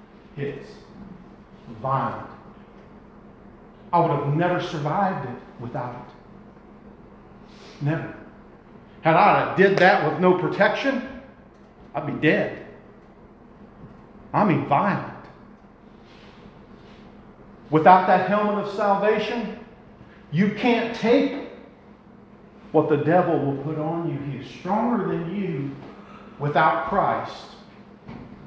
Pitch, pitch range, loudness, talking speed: 190 Hz, 160-215 Hz, -22 LUFS, 95 wpm